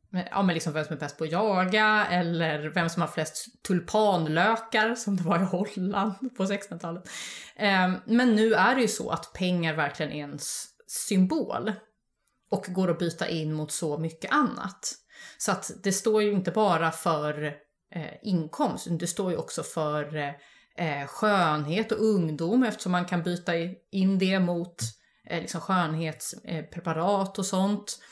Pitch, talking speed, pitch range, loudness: 180 Hz, 150 wpm, 160-205 Hz, -27 LUFS